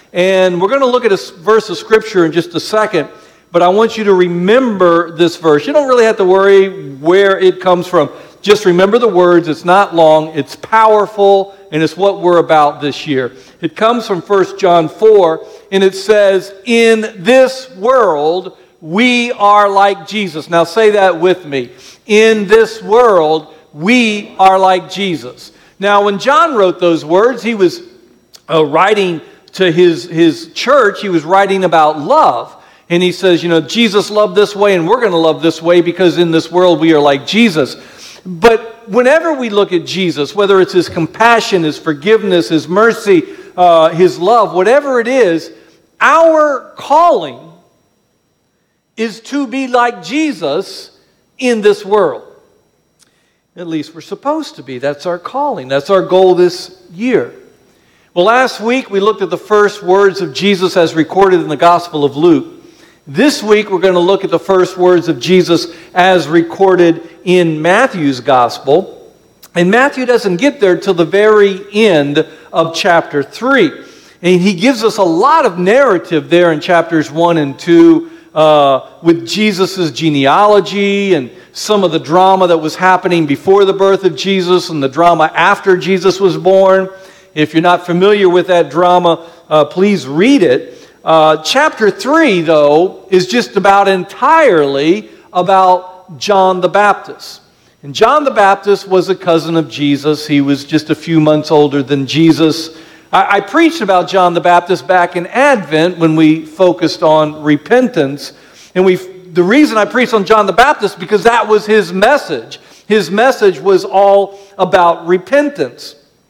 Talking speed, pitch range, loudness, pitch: 170 wpm, 170-215 Hz, -10 LUFS, 185 Hz